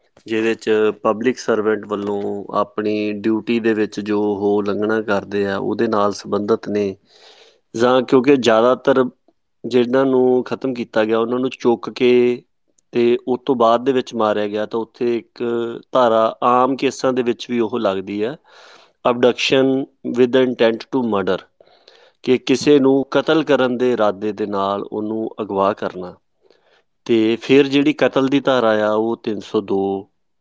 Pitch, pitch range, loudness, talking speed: 115 Hz, 105-125 Hz, -18 LUFS, 150 wpm